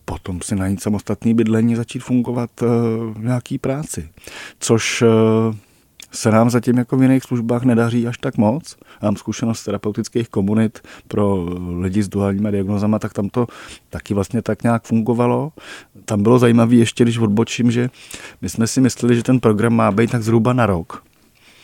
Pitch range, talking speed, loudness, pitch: 105-120 Hz, 170 wpm, -18 LUFS, 115 Hz